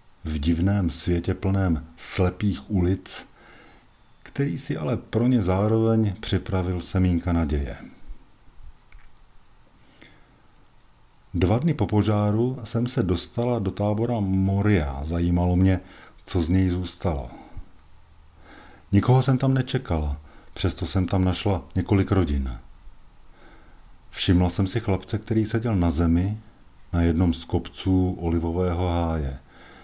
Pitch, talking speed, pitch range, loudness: 95 Hz, 110 wpm, 85-105 Hz, -24 LUFS